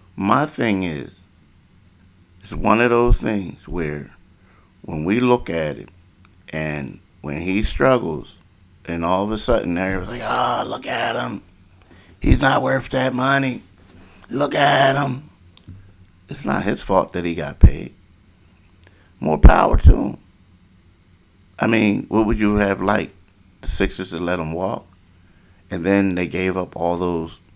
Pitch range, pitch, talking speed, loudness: 90-100 Hz, 95 Hz, 150 wpm, -20 LUFS